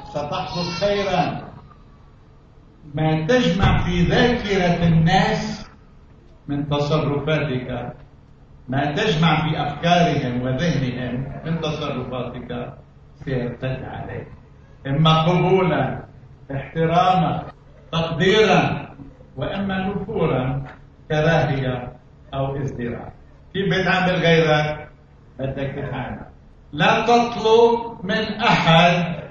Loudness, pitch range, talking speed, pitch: -20 LUFS, 135-180 Hz, 75 wpm, 150 Hz